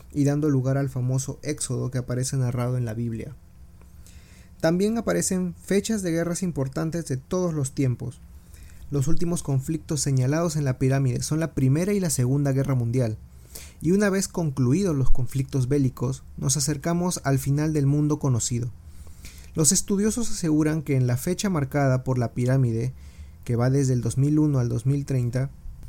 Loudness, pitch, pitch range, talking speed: -24 LUFS, 135 Hz, 125-155 Hz, 160 wpm